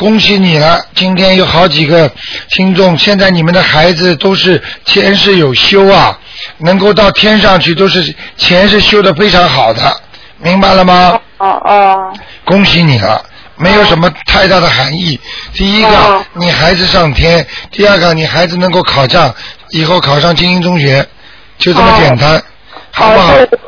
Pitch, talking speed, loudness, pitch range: 185 Hz, 240 characters per minute, -6 LUFS, 170-195 Hz